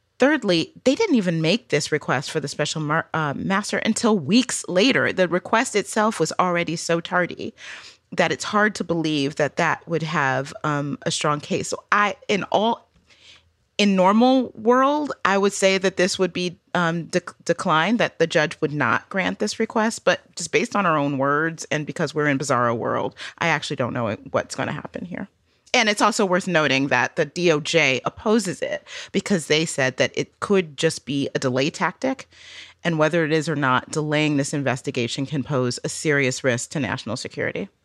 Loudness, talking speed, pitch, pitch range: -22 LUFS, 190 wpm, 160 Hz, 145-195 Hz